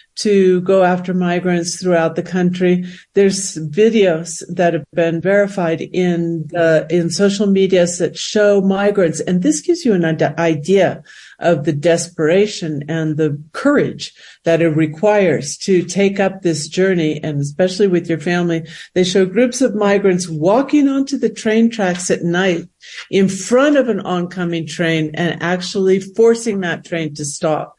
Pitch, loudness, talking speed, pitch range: 180 Hz, -16 LUFS, 155 wpm, 165-200 Hz